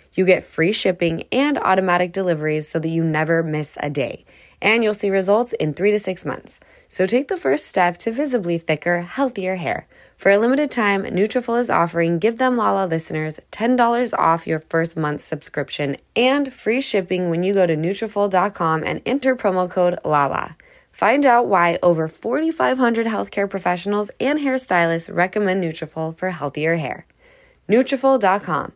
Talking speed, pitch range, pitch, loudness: 165 wpm, 165-235 Hz, 190 Hz, -19 LUFS